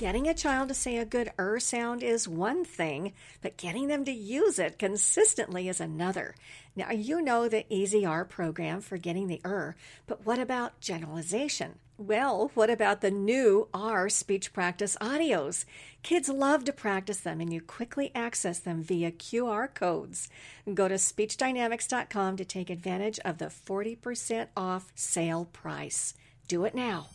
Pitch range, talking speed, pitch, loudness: 180-240 Hz, 160 wpm, 205 Hz, -30 LUFS